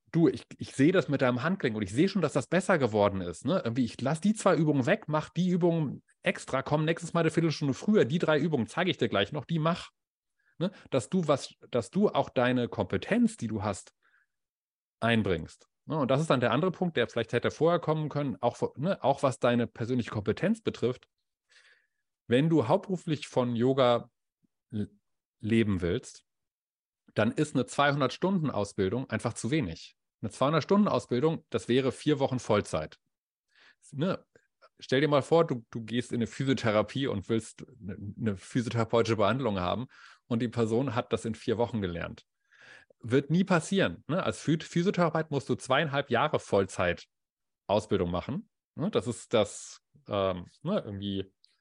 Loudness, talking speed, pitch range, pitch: -29 LUFS, 180 wpm, 115-160 Hz, 130 Hz